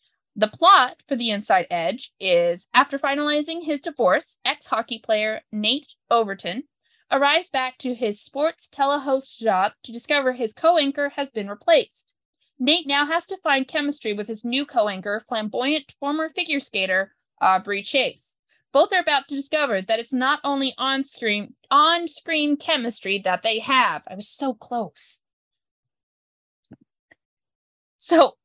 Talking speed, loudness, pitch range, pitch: 145 wpm, -22 LUFS, 215-290 Hz, 265 Hz